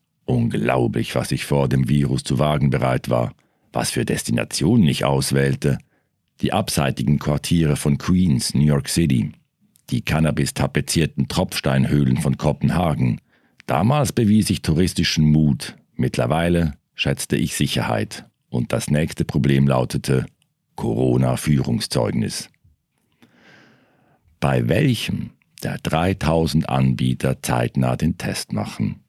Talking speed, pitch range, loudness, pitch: 110 wpm, 65-80 Hz, -20 LUFS, 70 Hz